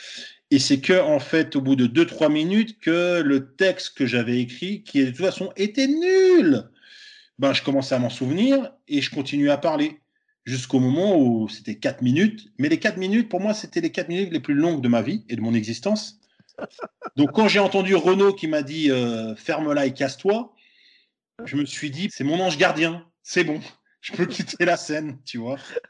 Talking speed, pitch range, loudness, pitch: 205 wpm, 140-215 Hz, -22 LUFS, 175 Hz